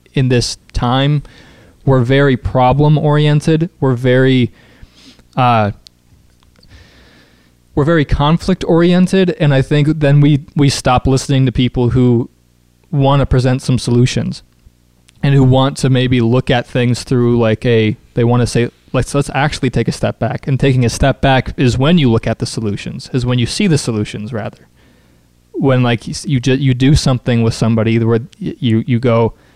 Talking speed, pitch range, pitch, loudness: 170 wpm, 115-140 Hz, 125 Hz, -13 LUFS